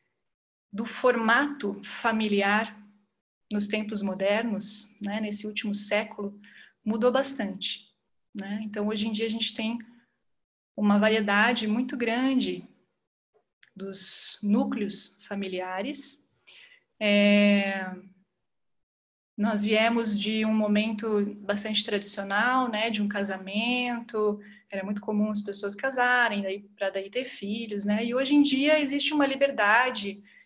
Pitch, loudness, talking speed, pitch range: 215 Hz, -27 LUFS, 110 wpm, 205-235 Hz